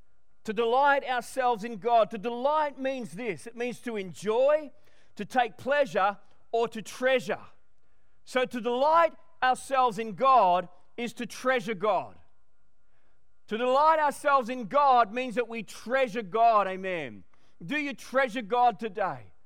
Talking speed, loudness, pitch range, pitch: 140 wpm, -27 LUFS, 225-265 Hz, 245 Hz